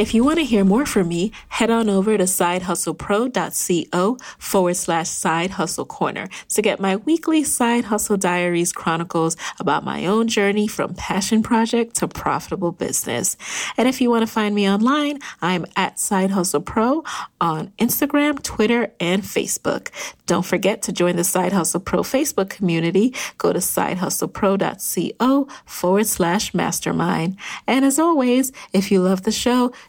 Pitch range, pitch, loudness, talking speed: 180-235 Hz, 205 Hz, -20 LUFS, 150 wpm